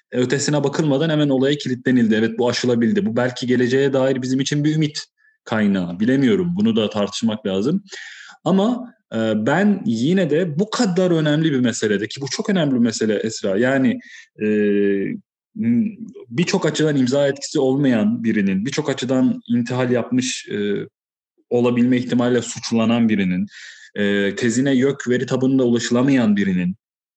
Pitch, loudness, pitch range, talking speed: 130 Hz, -19 LUFS, 120-165 Hz, 125 wpm